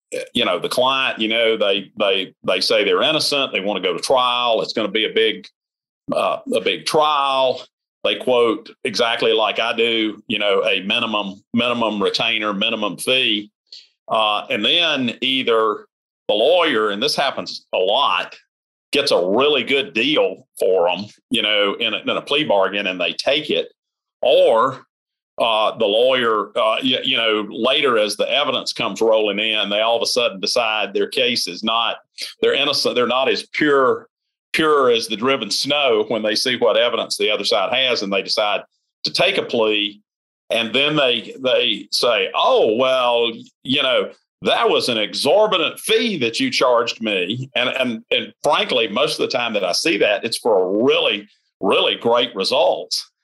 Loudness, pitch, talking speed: -18 LUFS, 155 Hz, 180 wpm